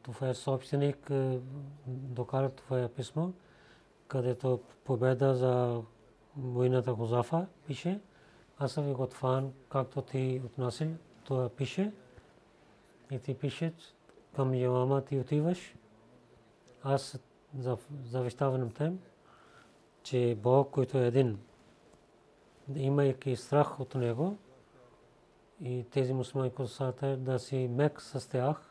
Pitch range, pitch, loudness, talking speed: 125-140 Hz, 130 Hz, -33 LUFS, 105 wpm